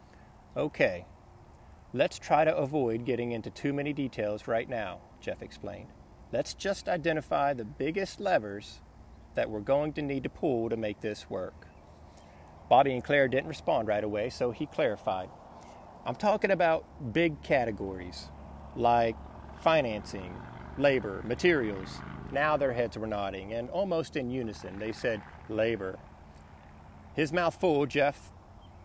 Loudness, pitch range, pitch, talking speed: -30 LUFS, 90-140 Hz, 110 Hz, 135 wpm